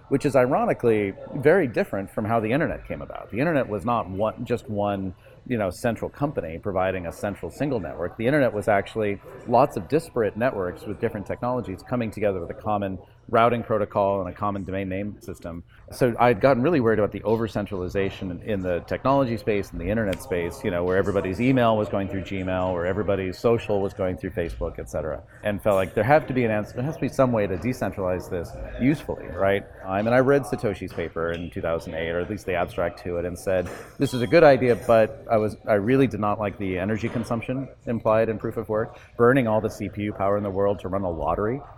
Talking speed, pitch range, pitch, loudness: 225 wpm, 95-115 Hz, 105 Hz, -24 LUFS